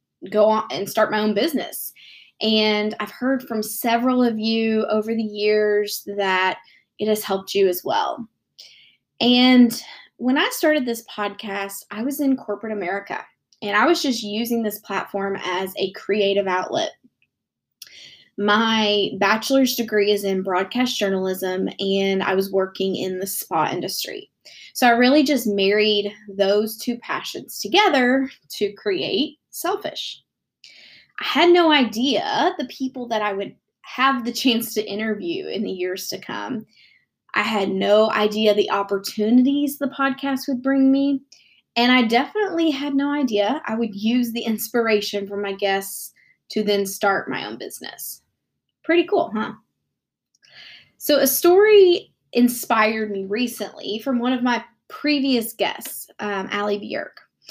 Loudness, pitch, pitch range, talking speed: -21 LUFS, 220 Hz, 205-265 Hz, 145 wpm